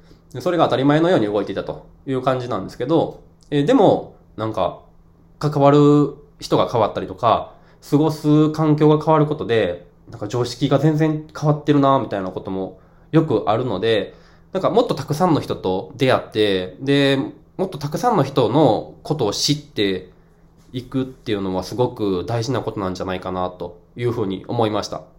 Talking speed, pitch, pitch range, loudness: 360 characters per minute, 130 Hz, 95-150 Hz, -19 LUFS